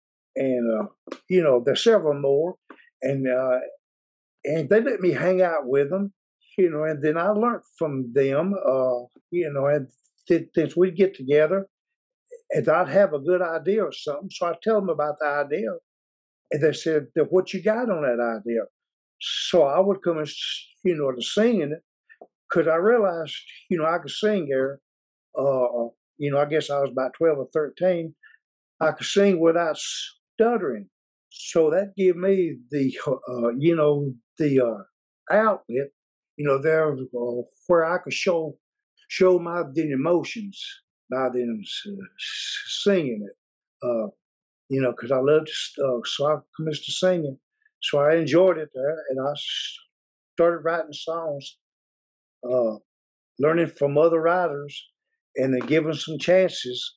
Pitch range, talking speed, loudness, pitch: 140-190 Hz, 160 wpm, -24 LUFS, 160 Hz